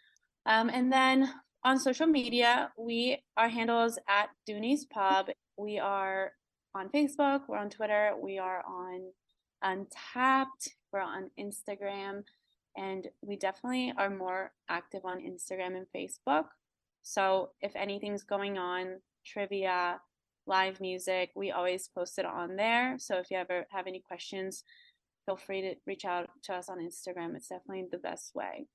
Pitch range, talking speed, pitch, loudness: 185-230 Hz, 150 wpm, 195 Hz, -33 LUFS